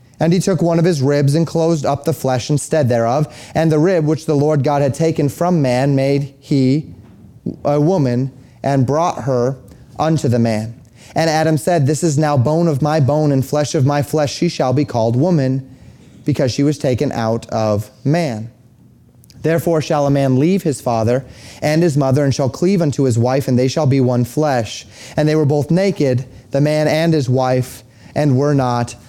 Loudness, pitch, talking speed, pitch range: -16 LUFS, 140 Hz, 200 wpm, 125-155 Hz